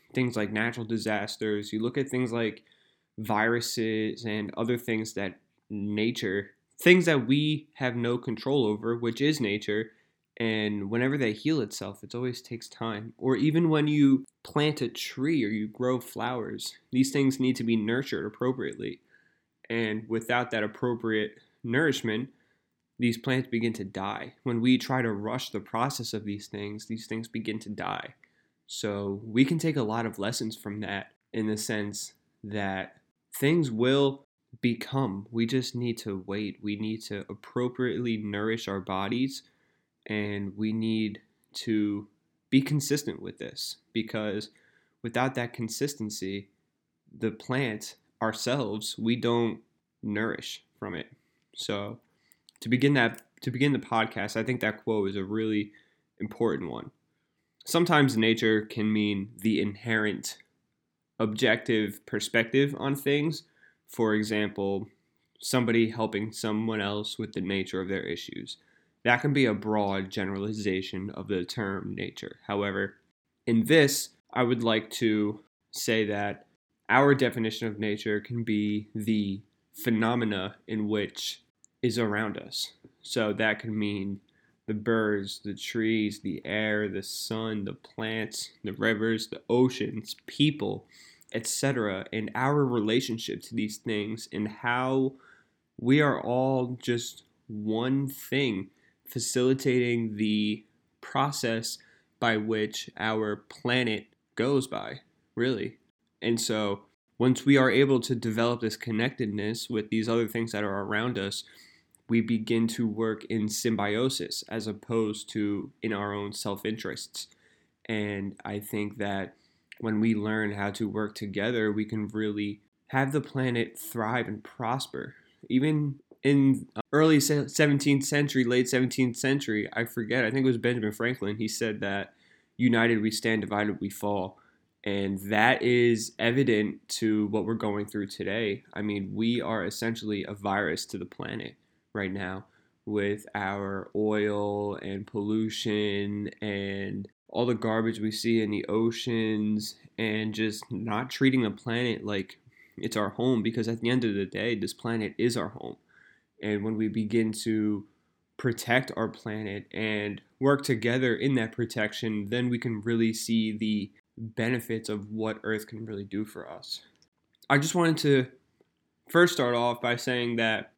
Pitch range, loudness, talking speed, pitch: 105-120 Hz, -29 LUFS, 145 wpm, 110 Hz